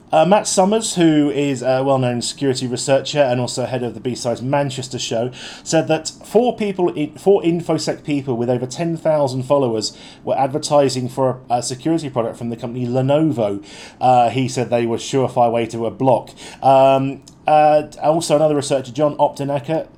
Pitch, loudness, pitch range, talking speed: 135 Hz, -18 LUFS, 125-150 Hz, 170 wpm